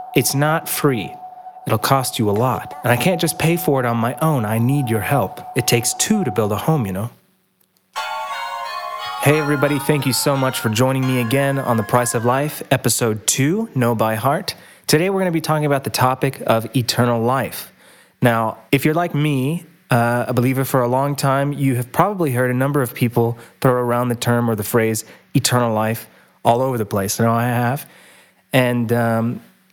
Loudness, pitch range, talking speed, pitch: -18 LUFS, 120-145 Hz, 205 wpm, 130 Hz